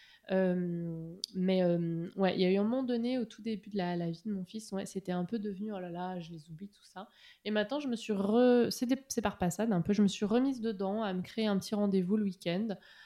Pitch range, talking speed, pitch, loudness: 180-220 Hz, 275 wpm, 200 Hz, -33 LUFS